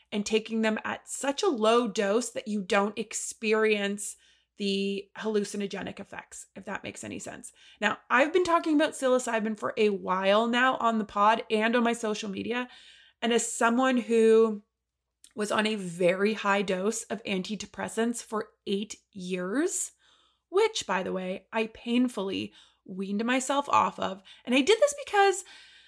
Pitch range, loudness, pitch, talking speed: 205-255 Hz, -27 LUFS, 225 Hz, 160 wpm